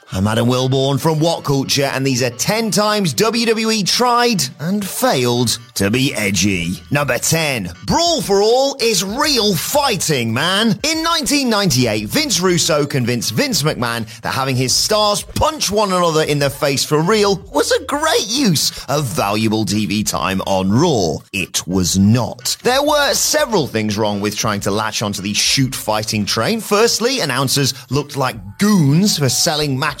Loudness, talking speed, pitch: -16 LUFS, 160 wpm, 145 Hz